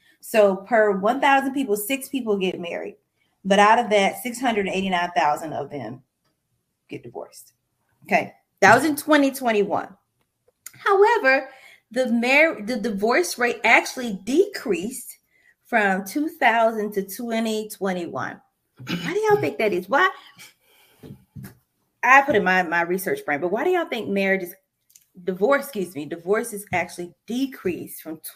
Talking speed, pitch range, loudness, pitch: 155 wpm, 190-270 Hz, -21 LUFS, 220 Hz